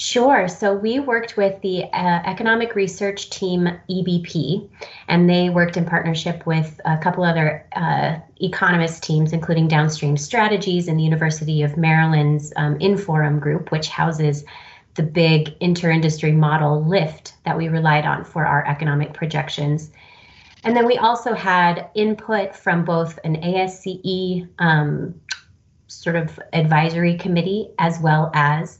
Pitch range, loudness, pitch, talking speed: 155-185 Hz, -19 LUFS, 170 Hz, 140 wpm